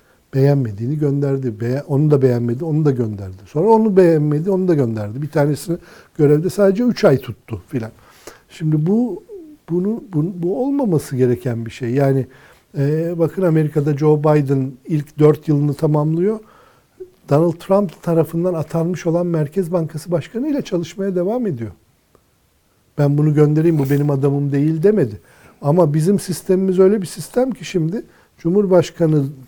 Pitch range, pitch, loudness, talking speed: 140-180 Hz, 155 Hz, -17 LUFS, 145 wpm